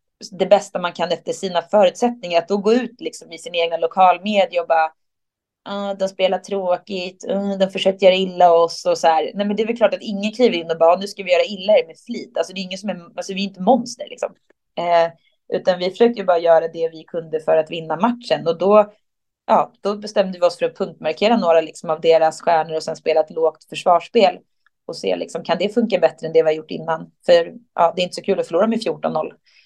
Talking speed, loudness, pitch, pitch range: 250 wpm, -19 LUFS, 185 Hz, 165-205 Hz